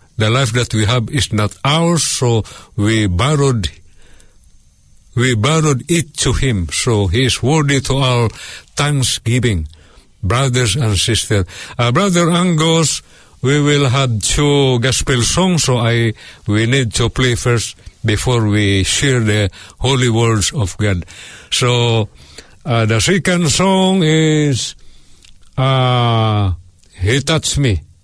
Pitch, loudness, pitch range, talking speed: 120 Hz, -14 LUFS, 105-140 Hz, 130 wpm